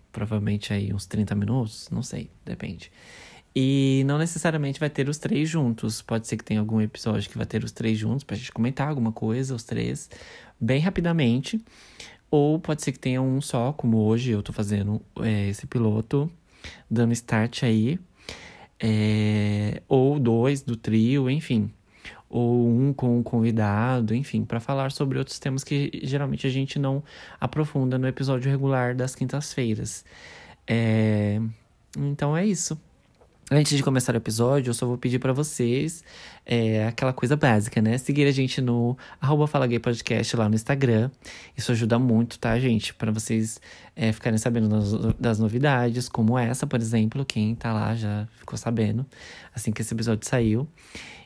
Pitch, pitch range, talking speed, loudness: 120 Hz, 110-135 Hz, 160 wpm, -25 LUFS